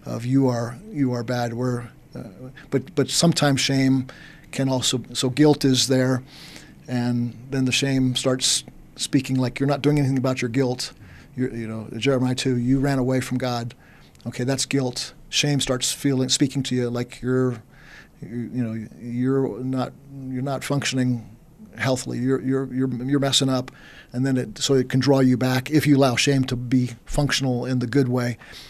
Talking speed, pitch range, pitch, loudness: 185 wpm, 125-135 Hz, 130 Hz, -22 LUFS